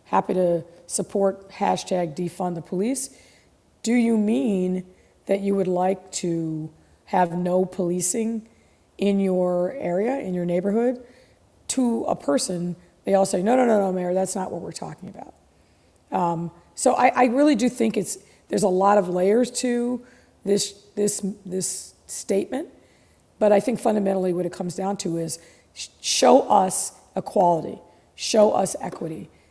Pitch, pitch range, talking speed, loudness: 195 Hz, 180-220 Hz, 155 wpm, -23 LUFS